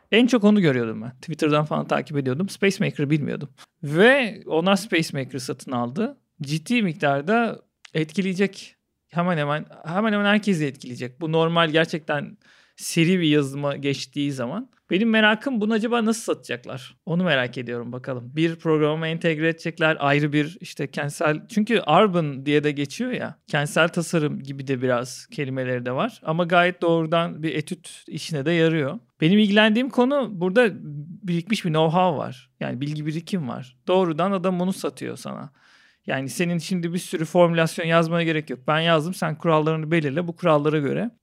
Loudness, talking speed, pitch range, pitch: -22 LUFS, 155 wpm, 150-190 Hz, 165 Hz